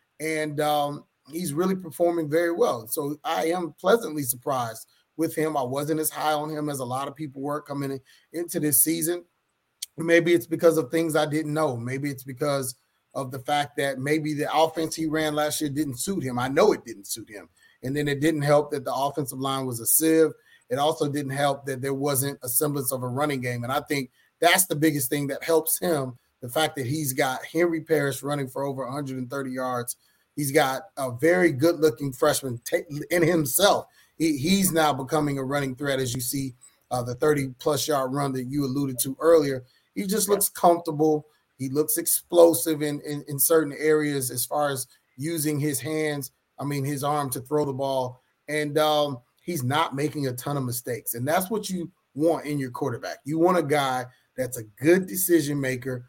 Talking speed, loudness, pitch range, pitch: 200 wpm, -25 LUFS, 135-160 Hz, 150 Hz